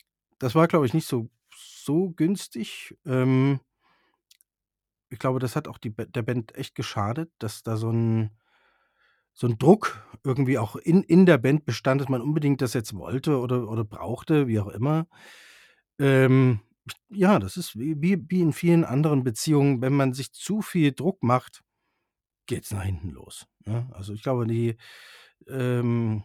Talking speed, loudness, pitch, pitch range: 165 wpm, -25 LUFS, 130 Hz, 115-155 Hz